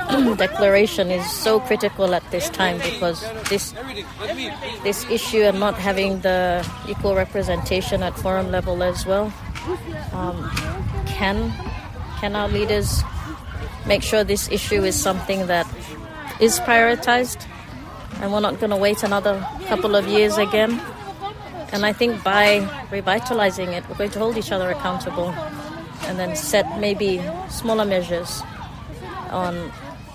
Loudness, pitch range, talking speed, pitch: -21 LUFS, 180-215 Hz, 135 wpm, 200 Hz